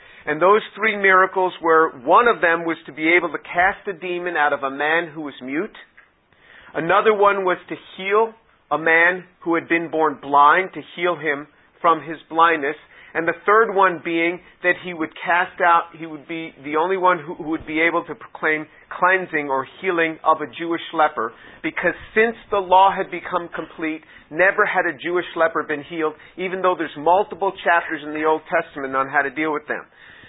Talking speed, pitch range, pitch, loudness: 200 wpm, 155-180 Hz, 170 Hz, -19 LUFS